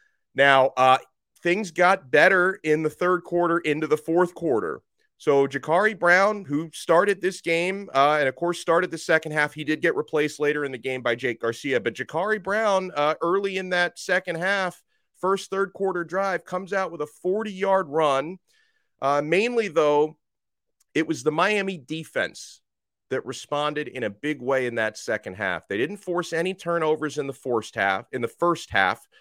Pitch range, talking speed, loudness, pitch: 145-190 Hz, 185 wpm, -24 LUFS, 165 Hz